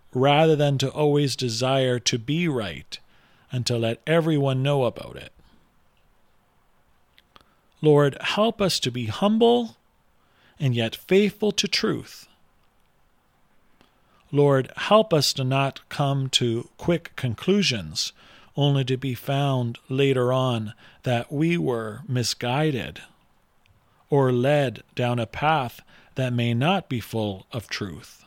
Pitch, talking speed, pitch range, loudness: 135 Hz, 120 wpm, 125-155 Hz, -23 LUFS